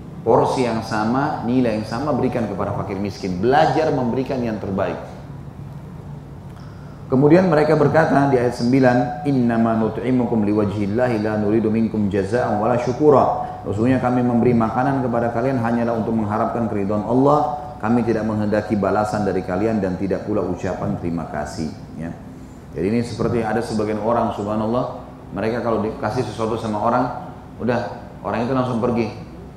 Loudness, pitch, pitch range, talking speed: -20 LUFS, 115 Hz, 105-130 Hz, 145 wpm